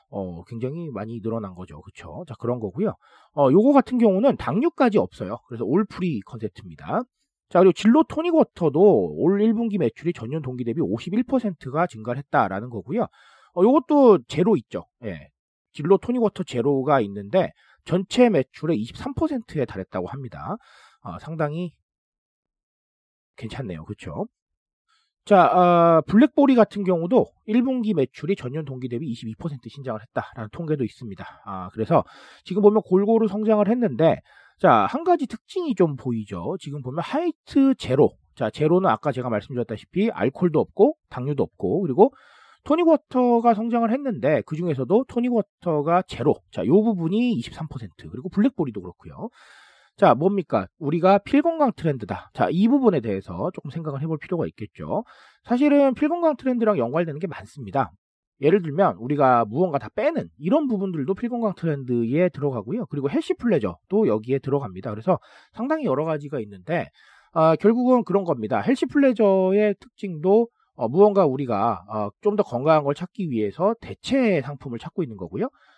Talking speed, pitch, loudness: 340 characters per minute, 175 Hz, -22 LUFS